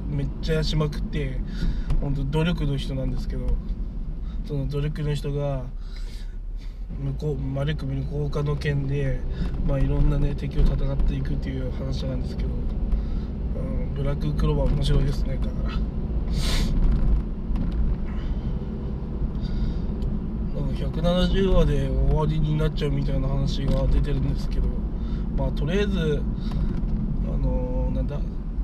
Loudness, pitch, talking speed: -27 LUFS, 135 Hz, 270 characters per minute